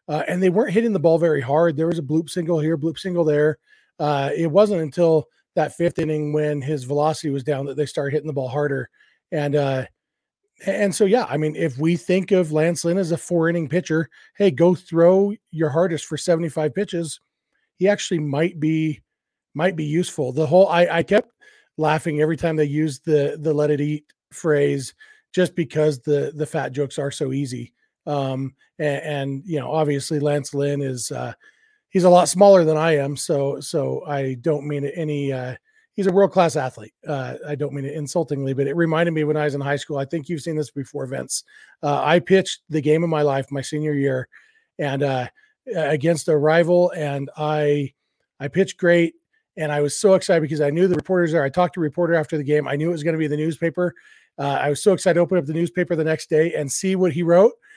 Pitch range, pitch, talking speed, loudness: 145-175 Hz, 155 Hz, 220 wpm, -21 LUFS